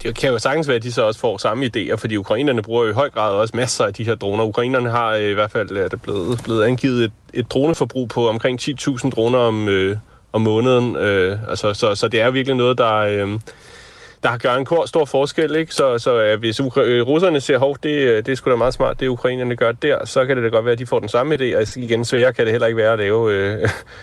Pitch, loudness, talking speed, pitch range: 120 Hz, -18 LUFS, 265 wpm, 110-130 Hz